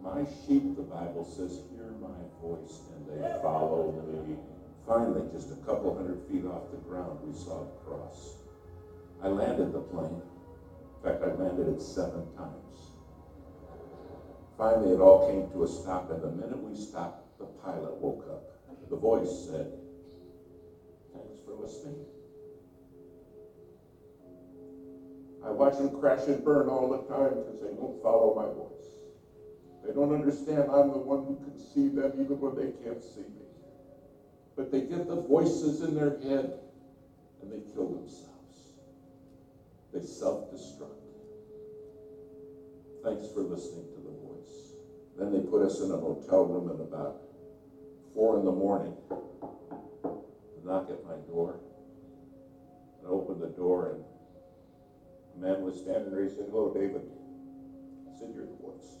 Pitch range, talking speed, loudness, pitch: 90-140 Hz, 145 wpm, -31 LUFS, 135 Hz